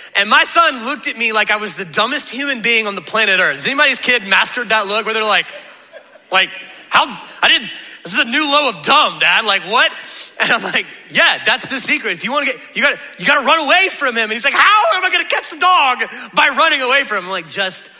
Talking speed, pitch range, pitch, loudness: 255 wpm, 215-295 Hz, 245 Hz, -13 LUFS